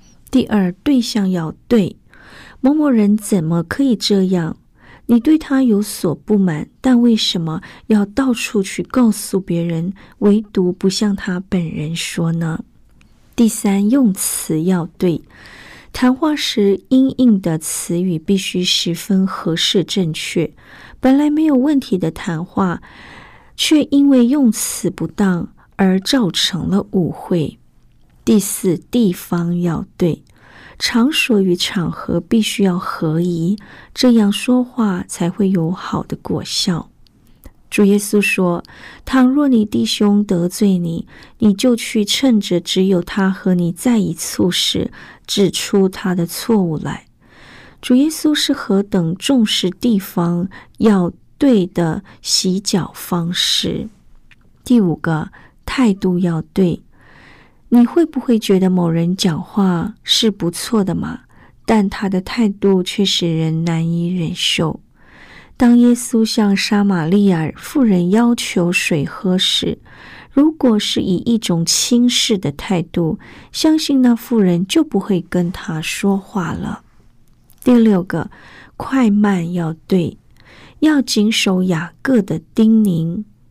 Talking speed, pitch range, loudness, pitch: 180 characters per minute, 175-235 Hz, -16 LUFS, 200 Hz